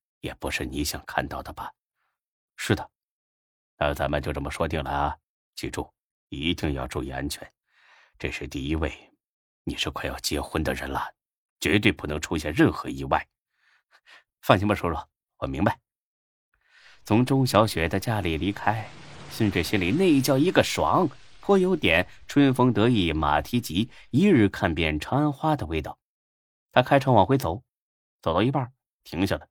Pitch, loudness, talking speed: 95 Hz, -25 LUFS, 230 characters per minute